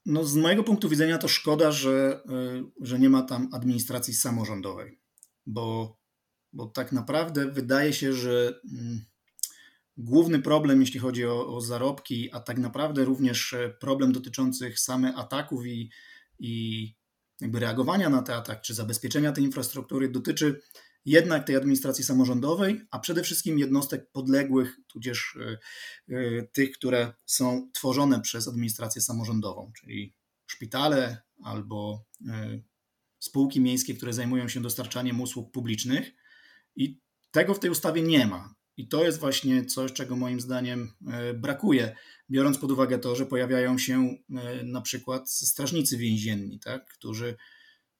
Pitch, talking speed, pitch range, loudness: 130 Hz, 130 wpm, 120-135 Hz, -27 LUFS